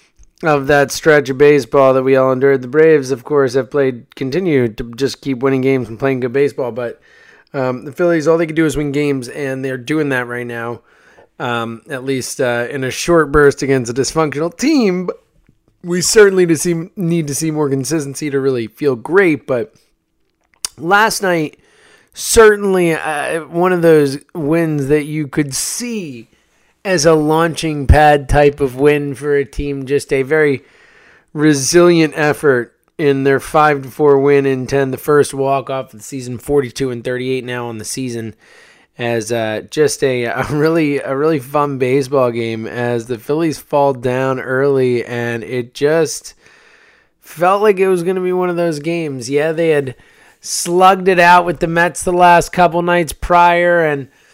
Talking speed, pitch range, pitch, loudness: 185 wpm, 130-165 Hz, 145 Hz, -14 LUFS